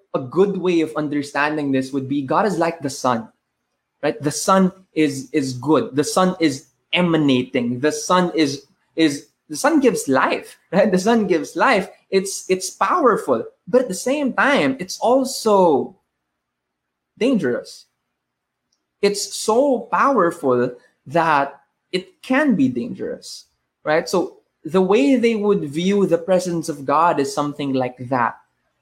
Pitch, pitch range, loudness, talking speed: 170 Hz, 145-200 Hz, -19 LUFS, 145 wpm